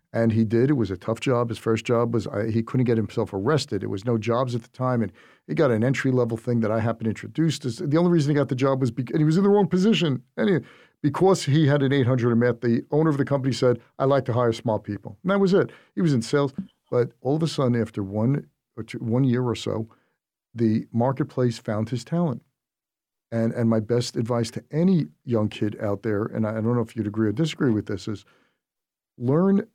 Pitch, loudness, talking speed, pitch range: 120 Hz, -24 LUFS, 250 wpm, 115-140 Hz